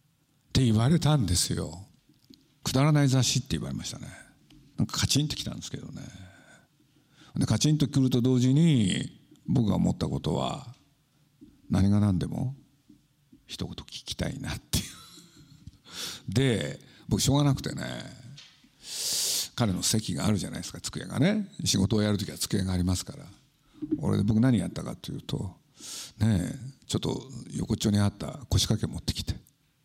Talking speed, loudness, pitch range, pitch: 315 characters per minute, -28 LUFS, 105-145 Hz, 130 Hz